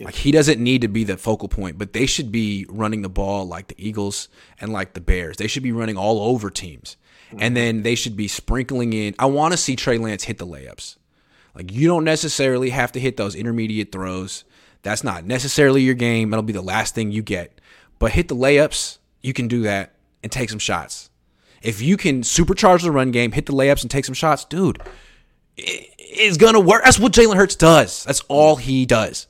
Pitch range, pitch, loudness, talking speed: 105-140 Hz, 120 Hz, -18 LUFS, 225 wpm